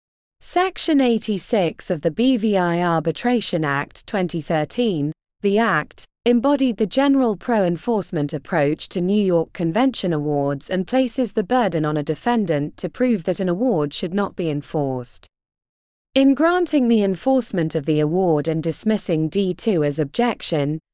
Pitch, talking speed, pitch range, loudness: 185 Hz, 140 wpm, 155-235 Hz, -20 LUFS